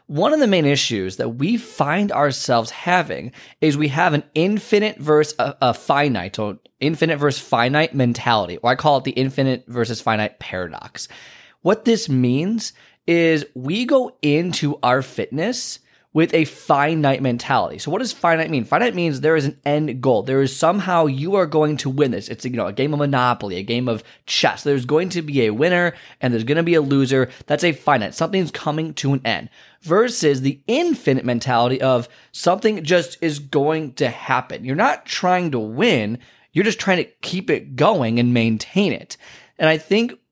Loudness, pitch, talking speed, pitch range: -19 LUFS, 145 Hz, 190 wpm, 125-170 Hz